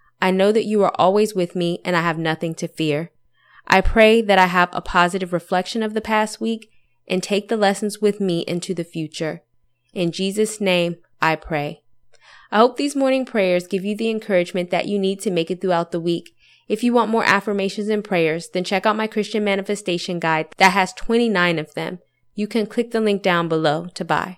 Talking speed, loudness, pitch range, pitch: 210 wpm, -20 LUFS, 170-215 Hz, 185 Hz